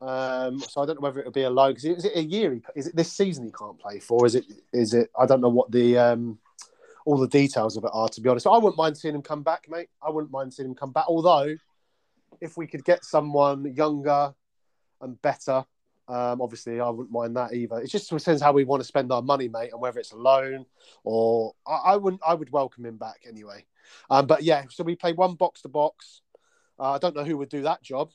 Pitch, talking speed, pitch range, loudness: 140 Hz, 255 wpm, 125-160 Hz, -24 LUFS